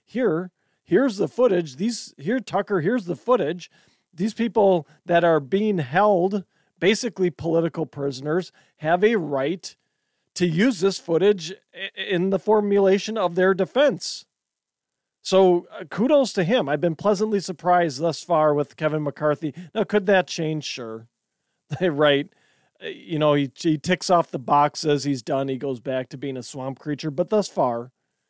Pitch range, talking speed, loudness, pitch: 150-200 Hz, 160 wpm, -22 LUFS, 175 Hz